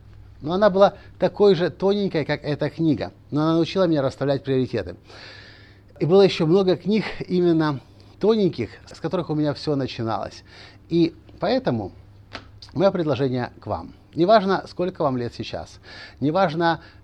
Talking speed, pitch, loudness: 140 wpm, 145 Hz, -22 LUFS